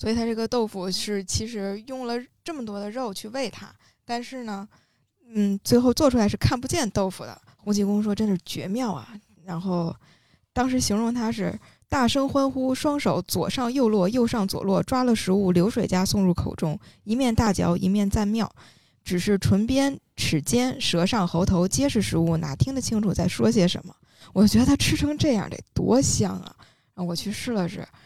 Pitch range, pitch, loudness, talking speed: 185-240 Hz, 205 Hz, -24 LUFS, 275 characters per minute